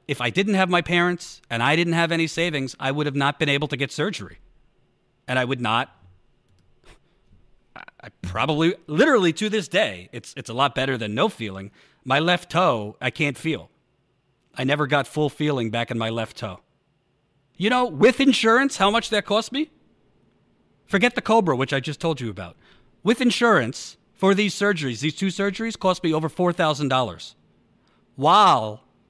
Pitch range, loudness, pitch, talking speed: 125-195 Hz, -22 LUFS, 150 Hz, 180 wpm